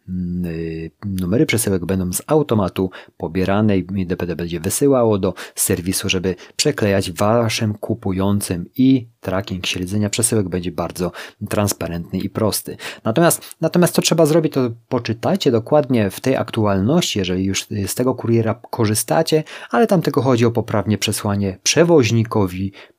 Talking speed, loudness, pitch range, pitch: 130 wpm, -18 LUFS, 95-125 Hz, 105 Hz